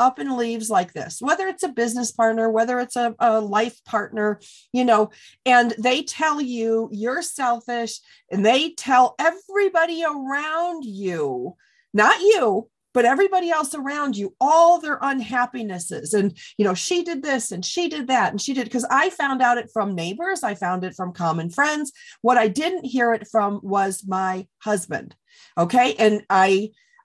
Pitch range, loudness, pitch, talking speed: 210-300 Hz, -21 LUFS, 245 Hz, 175 wpm